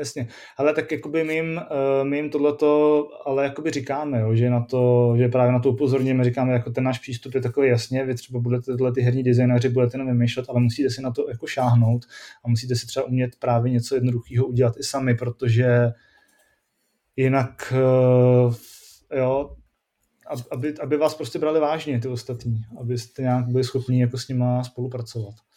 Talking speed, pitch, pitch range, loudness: 175 wpm, 130 Hz, 125-135 Hz, -22 LUFS